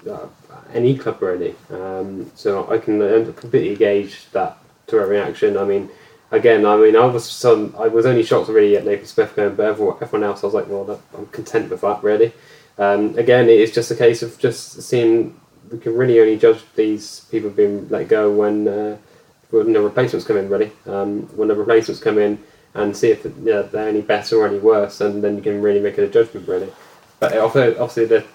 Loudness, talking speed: -17 LUFS, 215 wpm